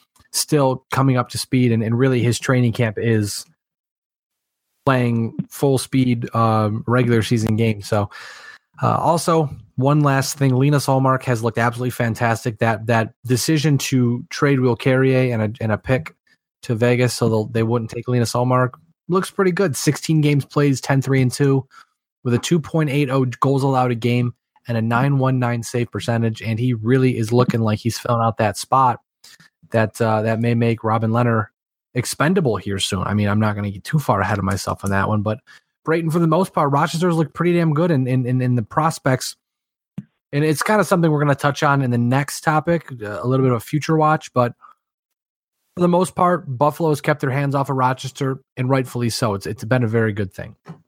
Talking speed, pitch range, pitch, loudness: 200 wpm, 115-145 Hz, 125 Hz, -19 LUFS